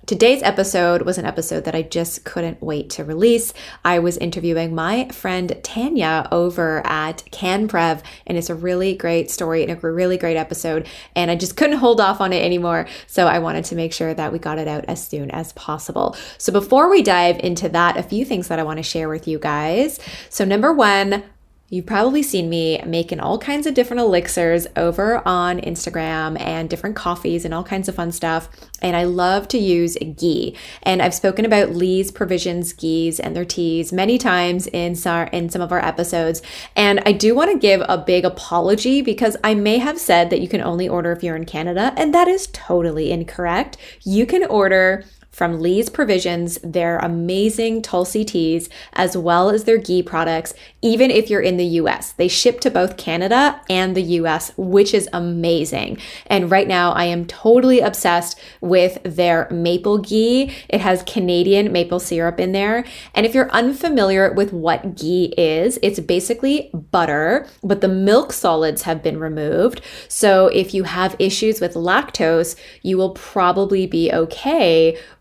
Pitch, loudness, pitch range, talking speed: 180 Hz, -18 LUFS, 170-205 Hz, 185 wpm